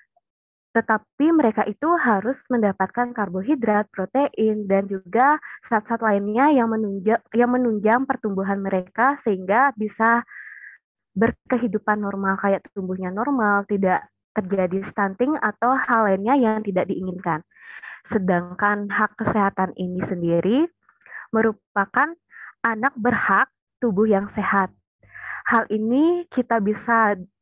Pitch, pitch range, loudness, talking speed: 215 Hz, 195-240 Hz, -21 LUFS, 105 wpm